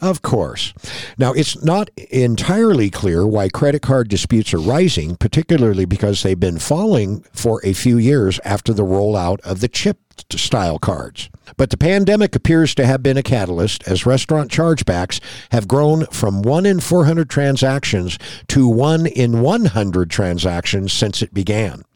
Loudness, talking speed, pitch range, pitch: -16 LUFS, 155 wpm, 100-150 Hz, 120 Hz